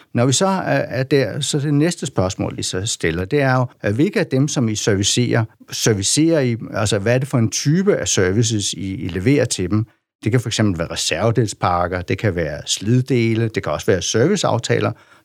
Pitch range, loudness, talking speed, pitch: 105-135 Hz, -18 LUFS, 200 wpm, 120 Hz